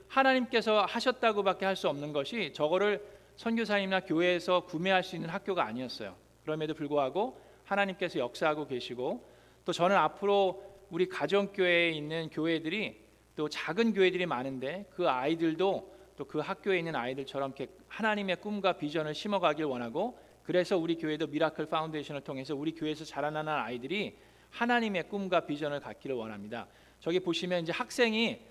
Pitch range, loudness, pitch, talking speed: 150-195 Hz, -32 LUFS, 170 Hz, 400 characters per minute